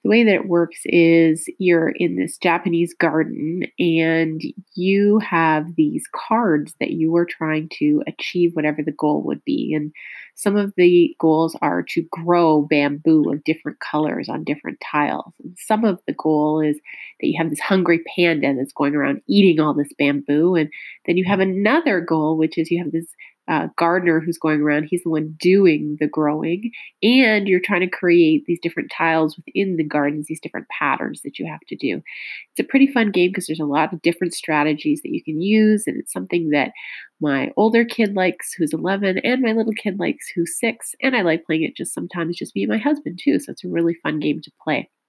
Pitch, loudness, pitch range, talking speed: 170 Hz, -19 LUFS, 155-190 Hz, 210 wpm